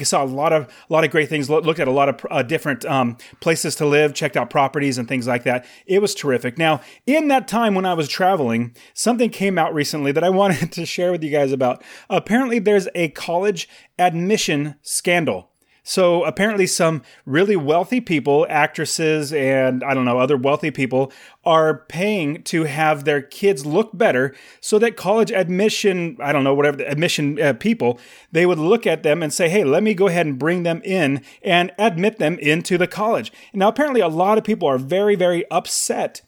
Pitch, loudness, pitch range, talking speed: 165 Hz, -19 LUFS, 145-195 Hz, 200 wpm